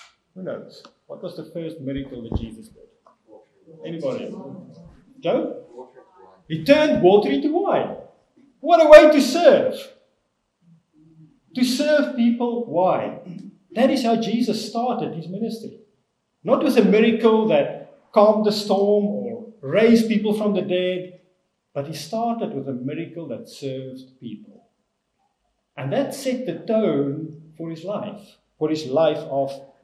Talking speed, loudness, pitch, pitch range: 140 wpm, -19 LUFS, 210 Hz, 160-235 Hz